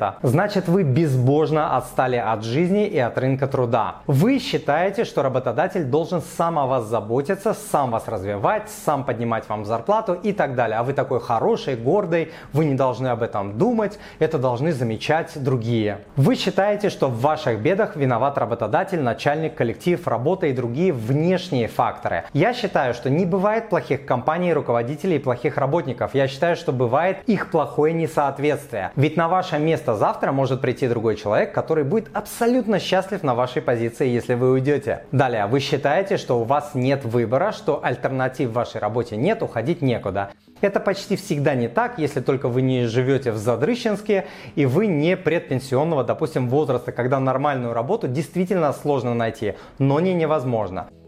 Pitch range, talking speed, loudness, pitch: 125-170 Hz, 165 wpm, -21 LUFS, 140 Hz